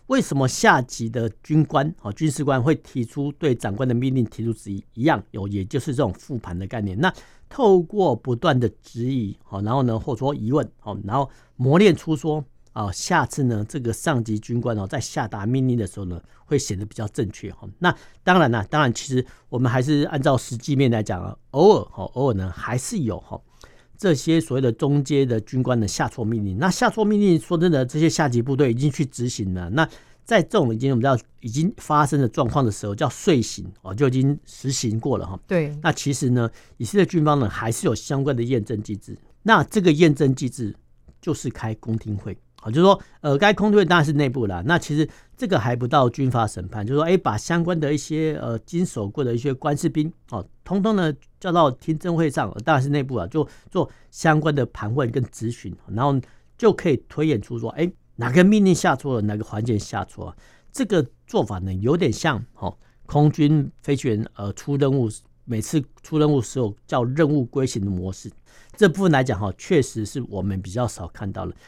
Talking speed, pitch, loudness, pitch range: 315 characters per minute, 130 Hz, -22 LUFS, 110-155 Hz